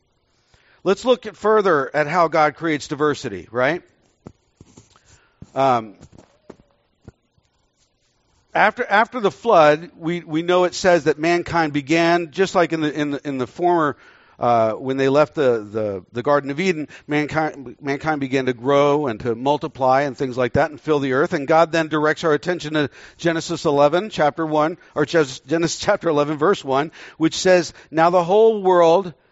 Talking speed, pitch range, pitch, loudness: 165 wpm, 140-170 Hz, 150 Hz, -19 LUFS